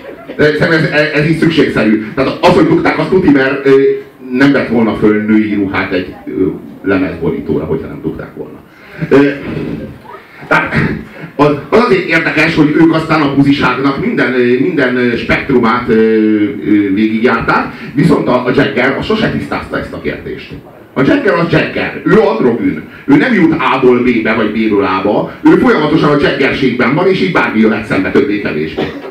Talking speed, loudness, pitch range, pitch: 150 wpm, -11 LUFS, 110-140 Hz, 125 Hz